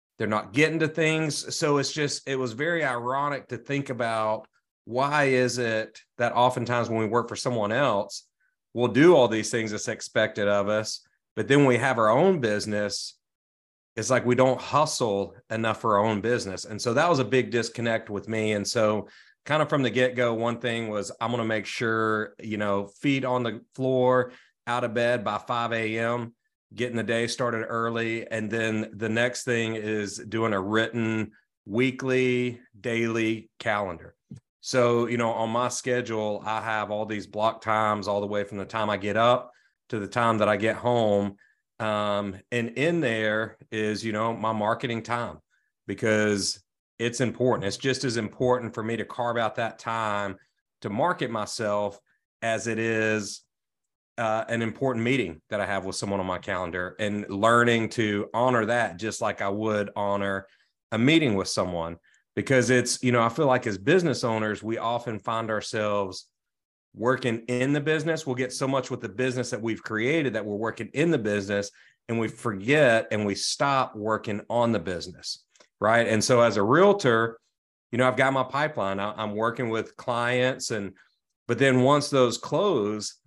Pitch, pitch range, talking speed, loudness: 115 Hz, 105-125 Hz, 185 wpm, -26 LUFS